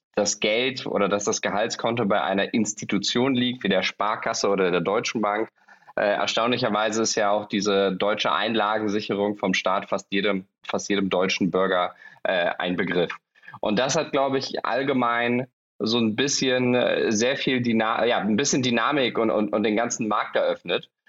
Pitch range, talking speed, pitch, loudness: 100-125 Hz, 160 wpm, 110 Hz, -23 LUFS